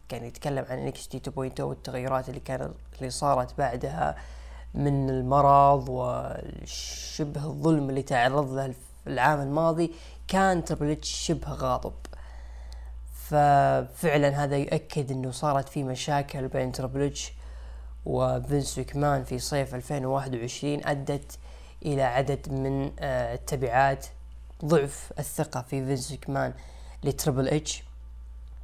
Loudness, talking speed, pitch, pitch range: -28 LUFS, 110 wpm, 135 Hz, 115-145 Hz